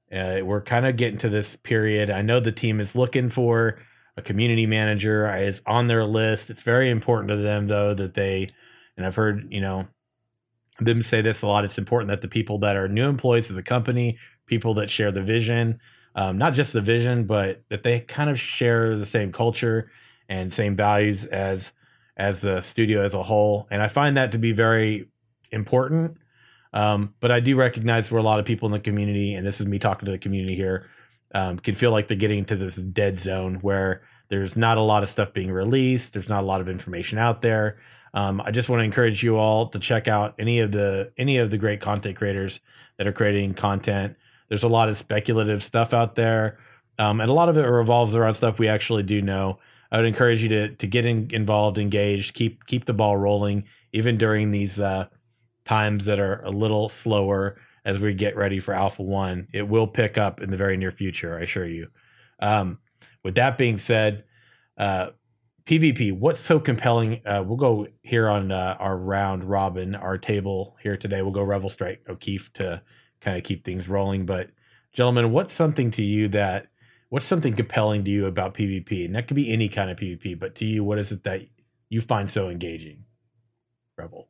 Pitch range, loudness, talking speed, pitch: 100-115 Hz, -23 LUFS, 210 wpm, 105 Hz